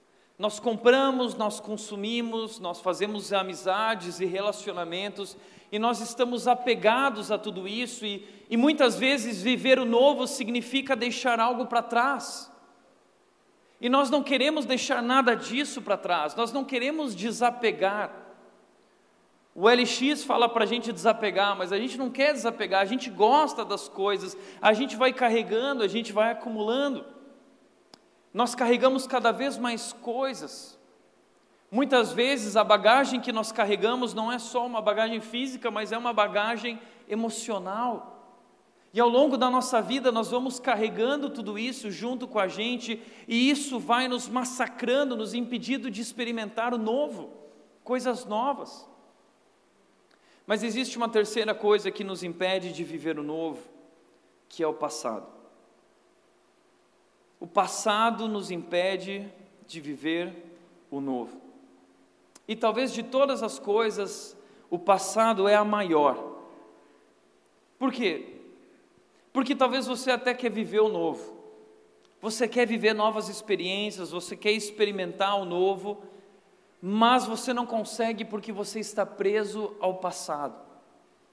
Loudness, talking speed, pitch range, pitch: -27 LUFS, 135 wpm, 200-245 Hz, 225 Hz